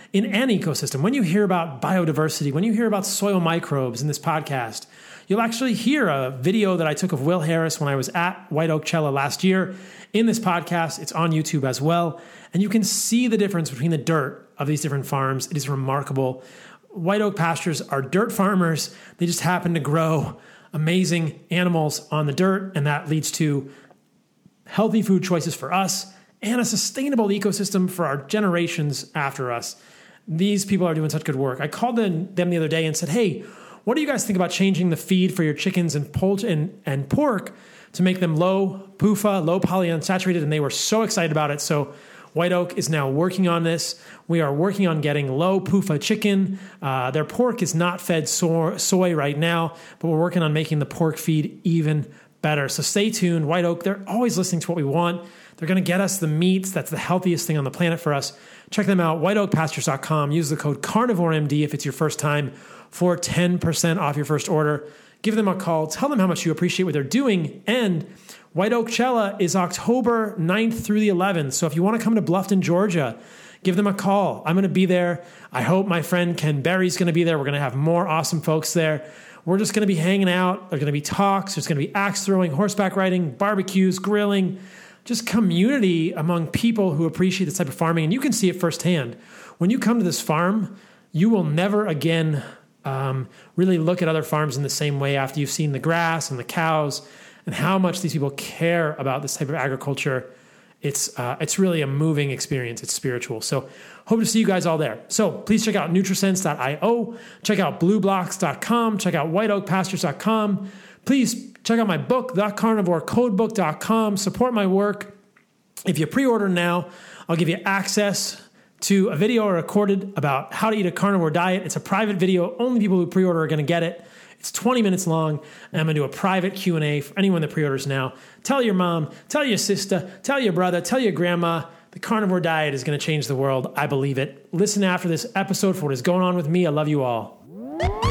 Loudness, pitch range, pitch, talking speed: -22 LUFS, 155-195 Hz, 175 Hz, 210 wpm